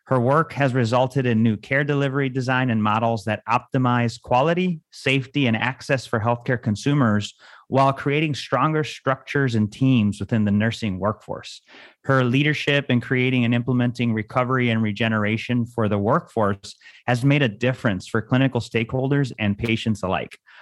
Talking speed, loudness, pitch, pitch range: 150 wpm, -21 LUFS, 125 Hz, 110-135 Hz